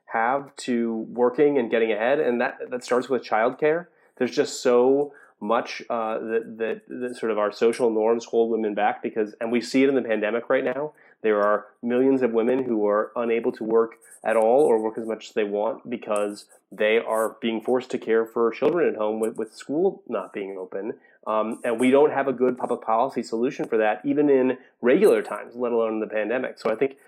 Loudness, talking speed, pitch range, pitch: -24 LUFS, 215 wpm, 110-125 Hz, 115 Hz